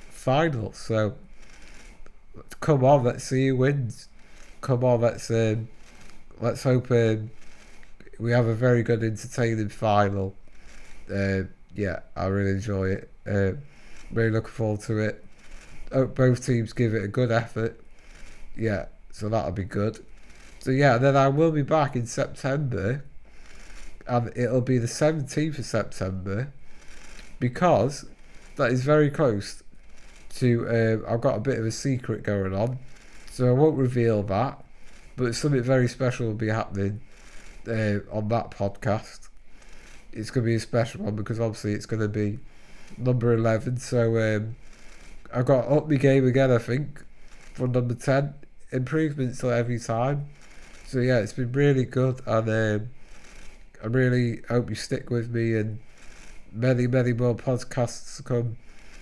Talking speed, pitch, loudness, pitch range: 150 wpm, 120 Hz, -25 LUFS, 110-130 Hz